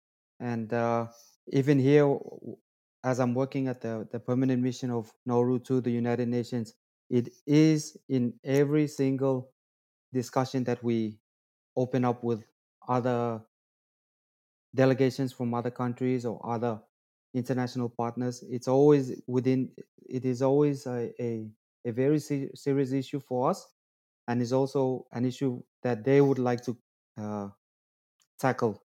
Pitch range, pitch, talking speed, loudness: 115-130 Hz, 125 Hz, 135 wpm, -29 LUFS